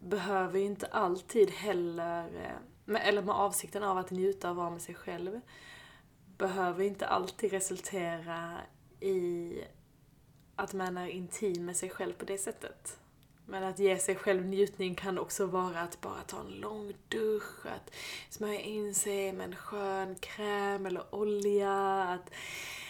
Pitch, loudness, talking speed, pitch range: 195 Hz, -35 LUFS, 145 wpm, 180-200 Hz